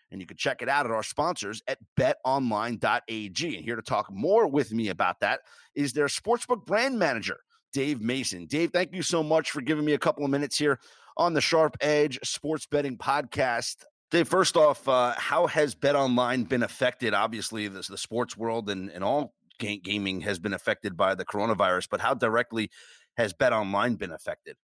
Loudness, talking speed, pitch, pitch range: -27 LUFS, 190 wpm, 135 Hz, 110-155 Hz